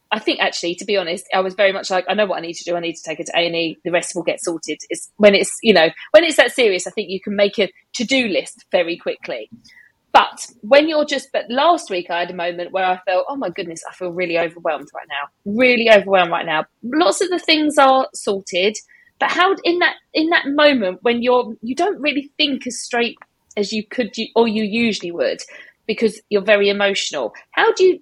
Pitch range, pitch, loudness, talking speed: 180-275 Hz, 215 Hz, -18 LUFS, 245 wpm